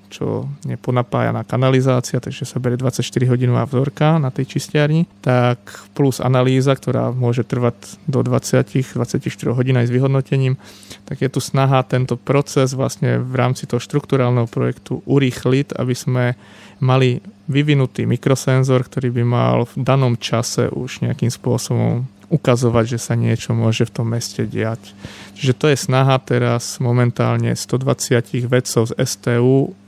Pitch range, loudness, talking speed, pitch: 120-135 Hz, -18 LUFS, 140 wpm, 125 Hz